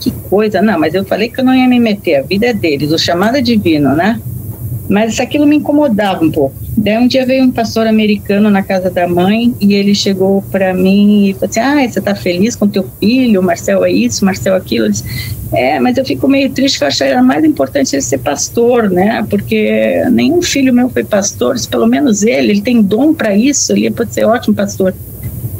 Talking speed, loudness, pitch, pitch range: 225 wpm, -11 LUFS, 205 Hz, 175-245 Hz